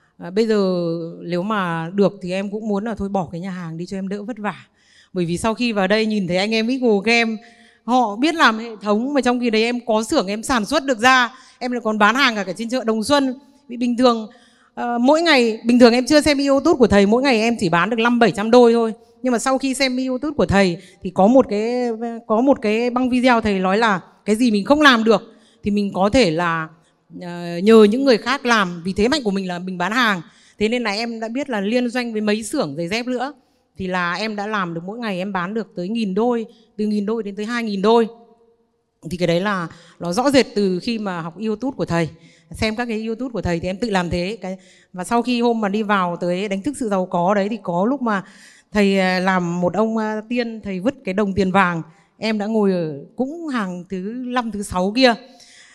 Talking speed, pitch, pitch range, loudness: 250 wpm, 220 Hz, 190-245 Hz, -19 LUFS